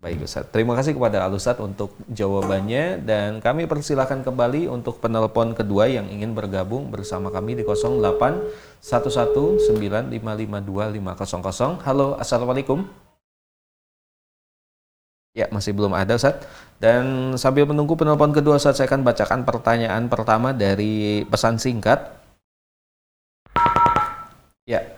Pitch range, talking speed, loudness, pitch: 105-140 Hz, 110 wpm, -21 LUFS, 115 Hz